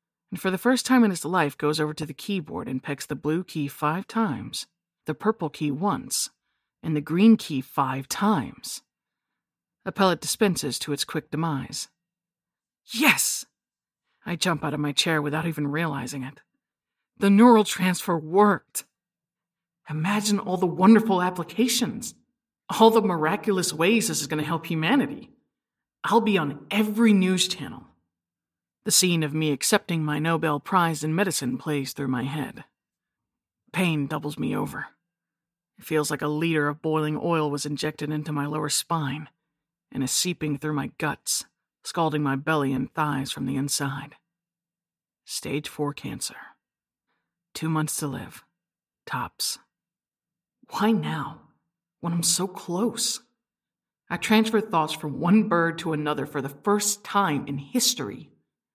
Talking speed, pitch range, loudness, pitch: 150 wpm, 150-195 Hz, -24 LUFS, 165 Hz